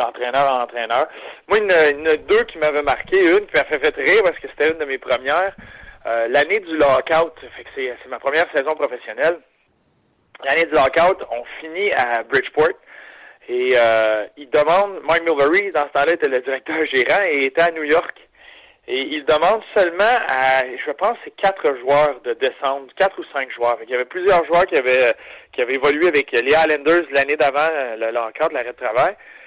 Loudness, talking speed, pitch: -18 LUFS, 200 wpm, 170 Hz